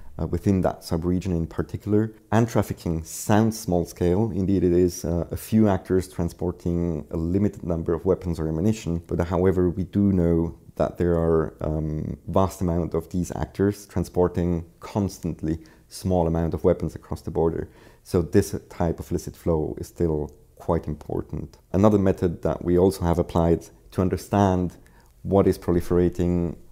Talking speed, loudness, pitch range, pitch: 160 wpm, -24 LUFS, 85-95 Hz, 90 Hz